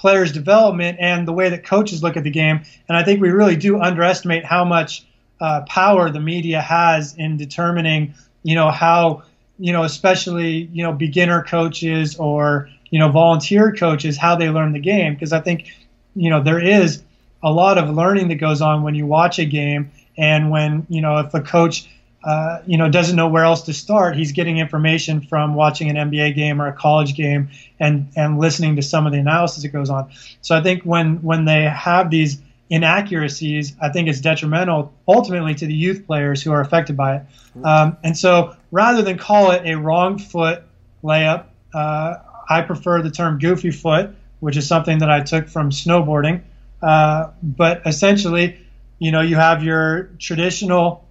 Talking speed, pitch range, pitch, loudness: 190 wpm, 150-175 Hz, 160 Hz, -17 LUFS